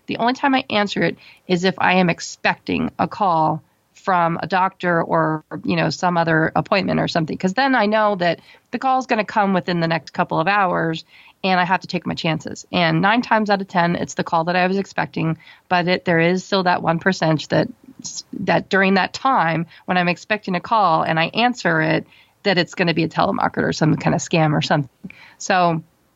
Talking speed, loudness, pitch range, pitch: 225 wpm, -19 LUFS, 165-200 Hz, 180 Hz